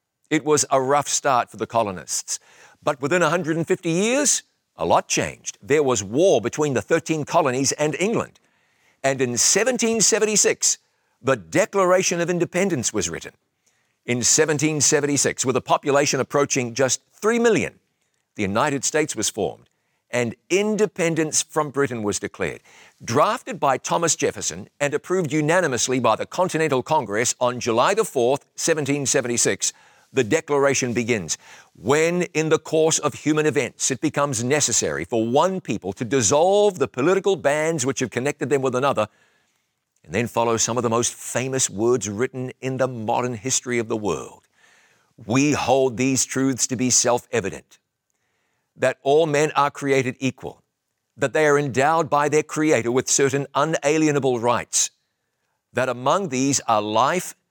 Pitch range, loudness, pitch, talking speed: 125-160 Hz, -21 LUFS, 140 Hz, 150 wpm